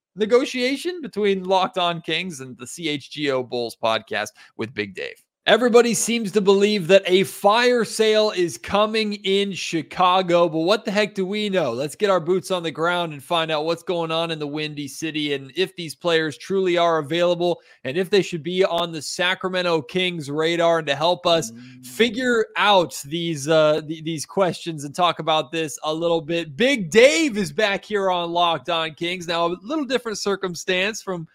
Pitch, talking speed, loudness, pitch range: 175 Hz, 190 wpm, -21 LUFS, 160-200 Hz